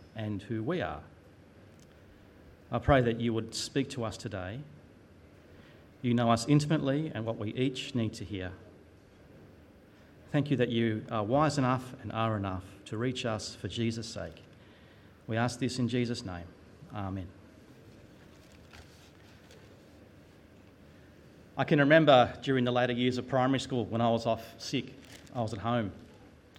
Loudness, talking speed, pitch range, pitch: -31 LUFS, 150 wpm, 95-125 Hz, 110 Hz